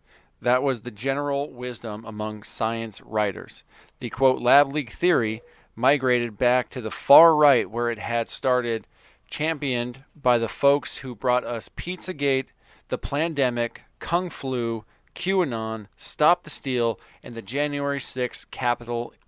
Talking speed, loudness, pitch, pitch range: 135 wpm, -24 LUFS, 125 Hz, 115-140 Hz